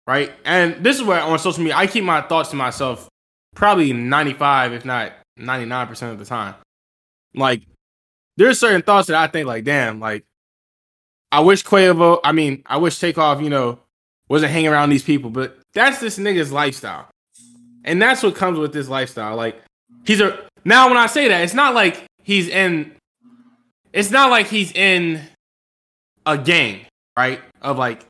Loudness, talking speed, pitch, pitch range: -16 LUFS, 175 wpm, 150 Hz, 120-190 Hz